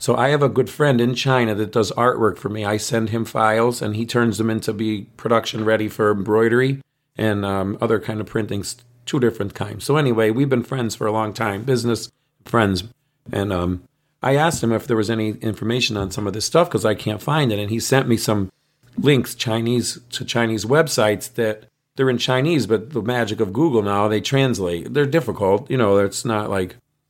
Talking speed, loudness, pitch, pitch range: 215 wpm, -20 LUFS, 115 Hz, 105-130 Hz